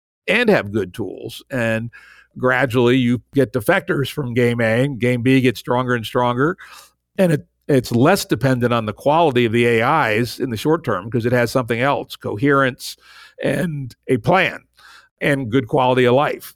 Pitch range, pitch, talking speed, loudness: 120-140 Hz, 130 Hz, 175 wpm, -18 LUFS